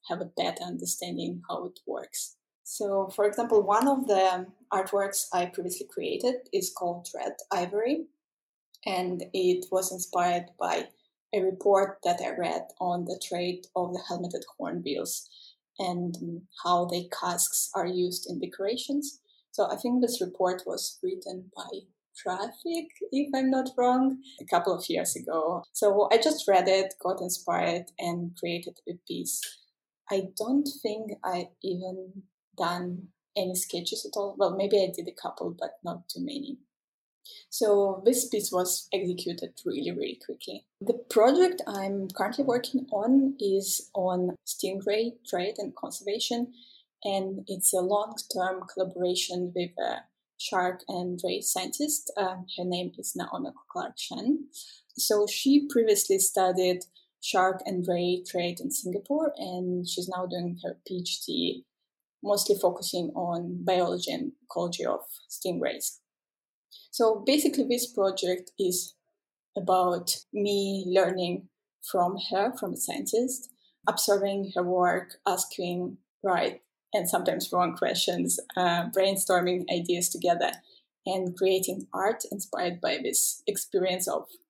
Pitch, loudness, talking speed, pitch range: 195 Hz, -29 LUFS, 135 wpm, 180-240 Hz